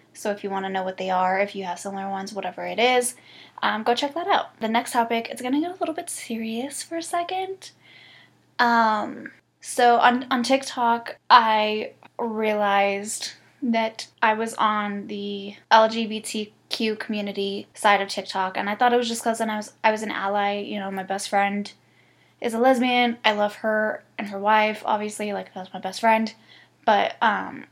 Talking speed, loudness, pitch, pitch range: 190 wpm, -23 LUFS, 215 Hz, 200-240 Hz